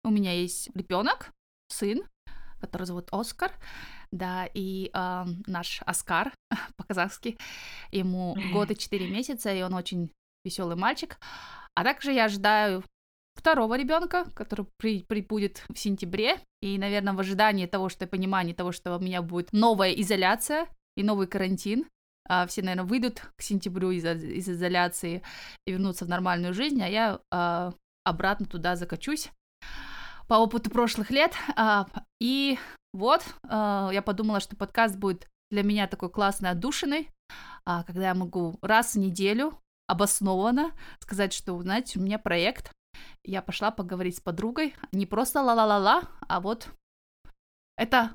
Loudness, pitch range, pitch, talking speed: -28 LUFS, 185-230 Hz, 200 Hz, 140 wpm